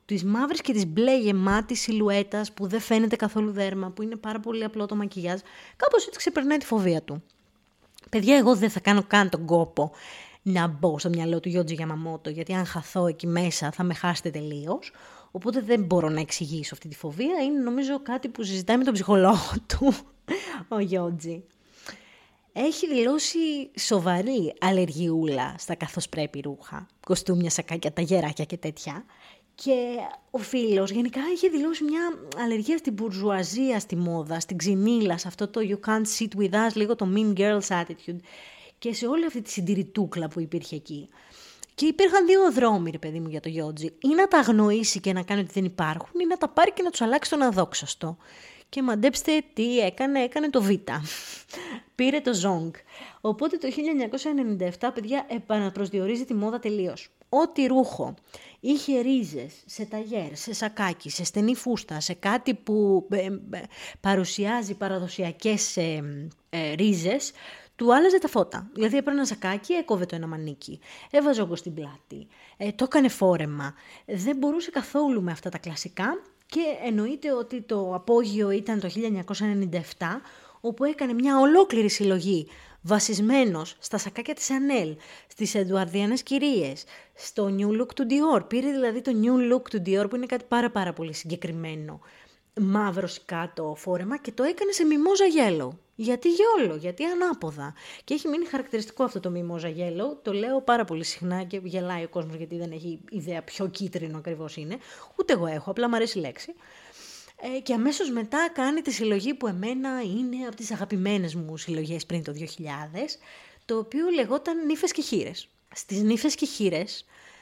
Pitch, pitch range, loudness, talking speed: 210 Hz, 175-260 Hz, -26 LUFS, 165 wpm